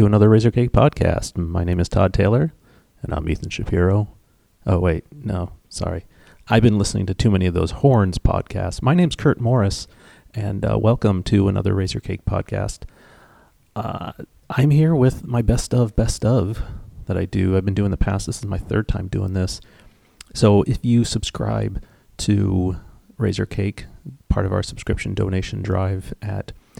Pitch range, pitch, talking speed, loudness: 95-115 Hz, 100 Hz, 170 wpm, -20 LUFS